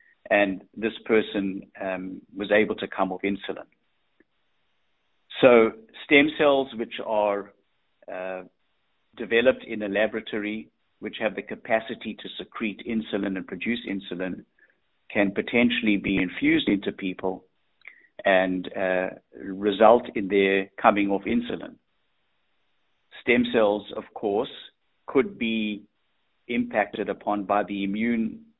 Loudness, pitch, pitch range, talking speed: -25 LUFS, 105 Hz, 95-115 Hz, 115 wpm